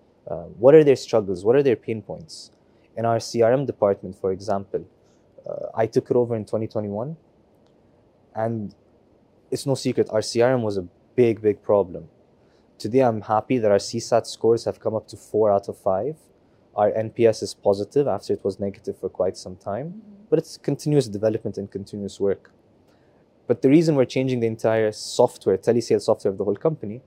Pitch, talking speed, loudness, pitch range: 115 Hz, 180 wpm, -22 LUFS, 105-130 Hz